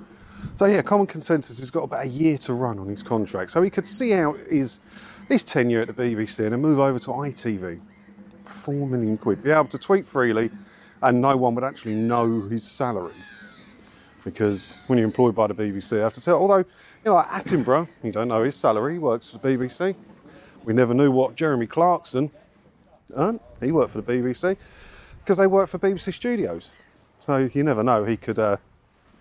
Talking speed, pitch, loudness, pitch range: 200 wpm, 125 Hz, -23 LUFS, 110-160 Hz